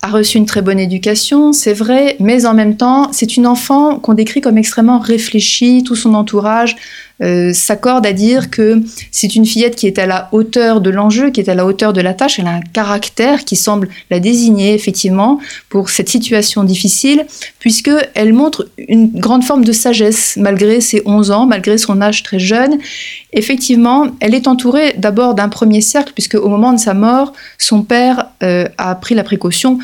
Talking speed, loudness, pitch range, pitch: 195 wpm, -11 LUFS, 205-245 Hz, 220 Hz